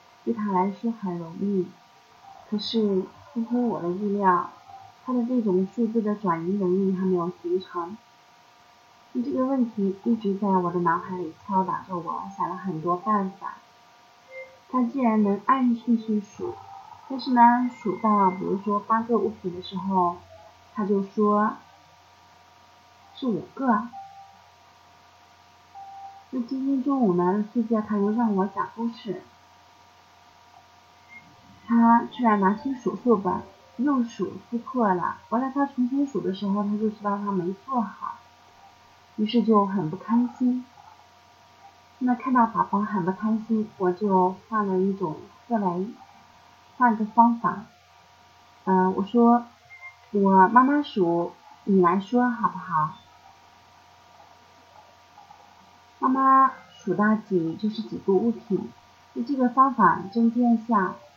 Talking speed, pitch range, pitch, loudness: 185 characters per minute, 190-240 Hz, 215 Hz, -24 LUFS